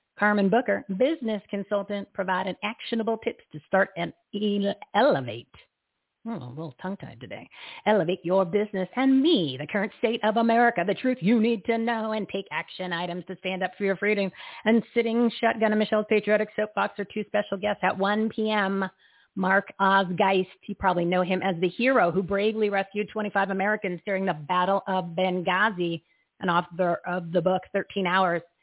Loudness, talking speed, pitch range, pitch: -26 LUFS, 175 wpm, 185-215 Hz, 200 Hz